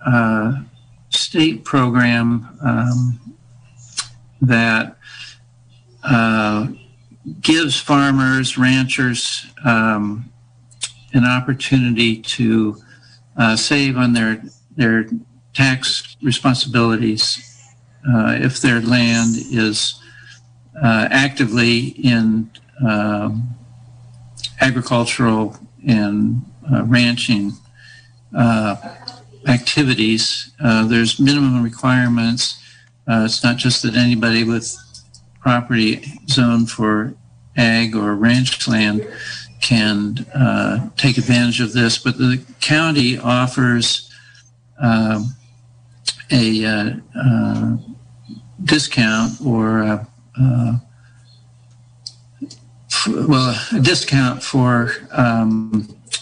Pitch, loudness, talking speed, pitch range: 120 Hz, -16 LUFS, 85 wpm, 115-125 Hz